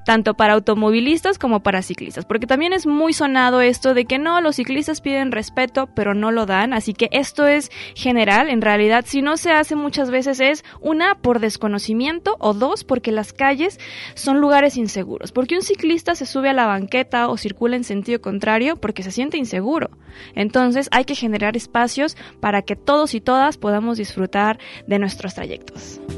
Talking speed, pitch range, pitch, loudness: 185 wpm, 215-280 Hz, 245 Hz, -18 LUFS